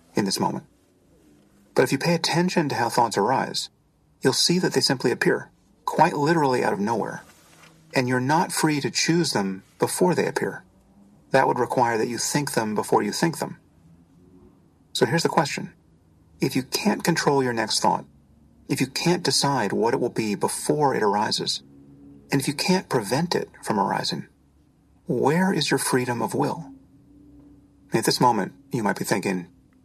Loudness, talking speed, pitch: -23 LUFS, 175 wpm, 135 Hz